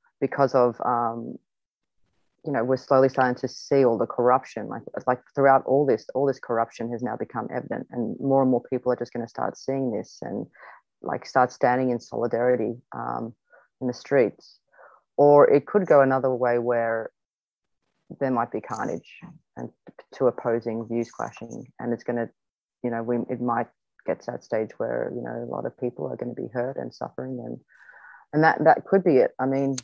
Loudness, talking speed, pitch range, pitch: -24 LUFS, 200 wpm, 120-135 Hz, 125 Hz